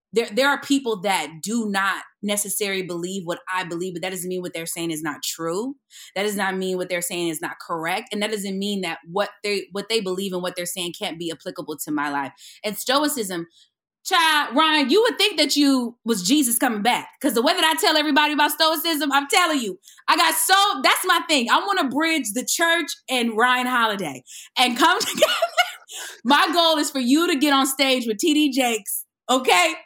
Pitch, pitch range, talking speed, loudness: 235 Hz, 185-300 Hz, 215 wpm, -21 LUFS